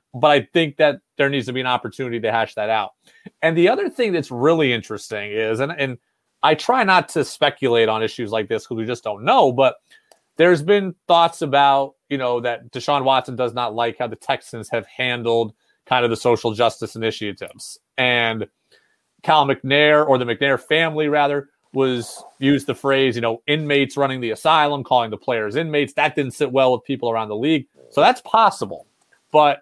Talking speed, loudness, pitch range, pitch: 195 wpm, -19 LUFS, 115-145 Hz, 130 Hz